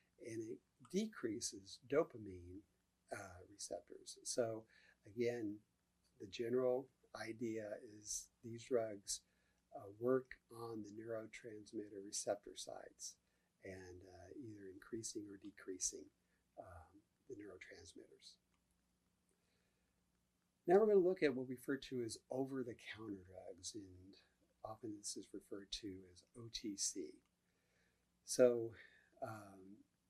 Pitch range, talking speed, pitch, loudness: 100-155 Hz, 110 wpm, 115 Hz, -44 LUFS